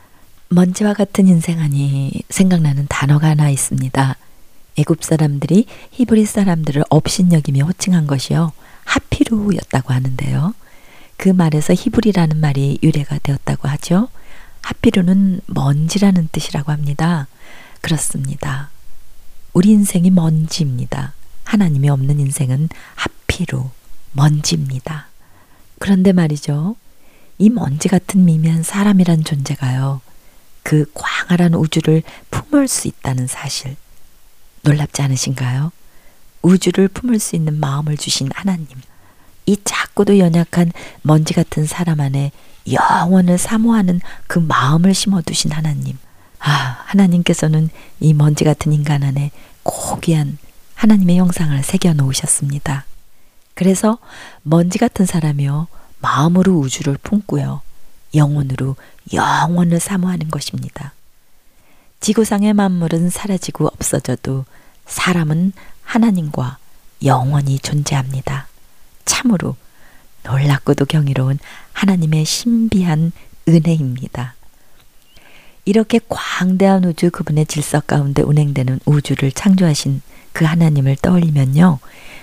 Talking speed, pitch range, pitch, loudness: 275 characters per minute, 140-180 Hz, 155 Hz, -16 LUFS